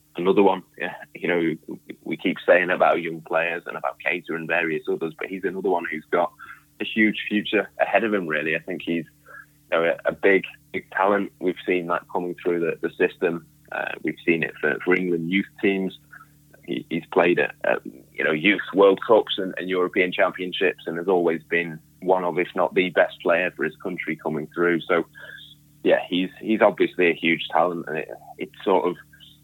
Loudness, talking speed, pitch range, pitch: -23 LUFS, 200 wpm, 80-90 Hz, 85 Hz